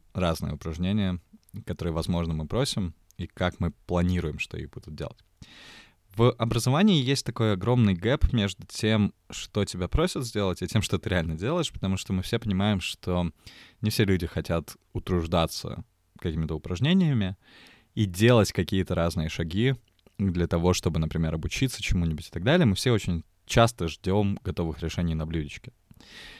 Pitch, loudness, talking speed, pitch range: 95 Hz, -27 LUFS, 155 wpm, 85-110 Hz